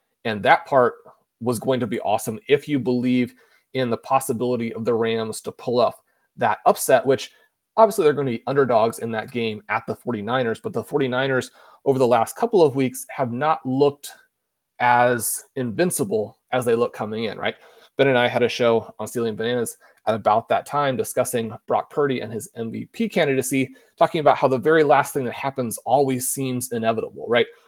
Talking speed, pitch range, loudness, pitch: 190 wpm, 115-140 Hz, -22 LUFS, 130 Hz